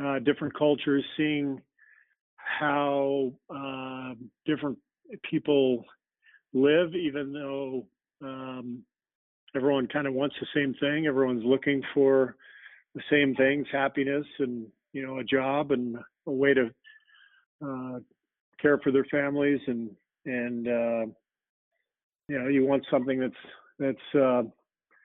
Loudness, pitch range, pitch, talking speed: -28 LUFS, 130-145 Hz, 135 Hz, 120 wpm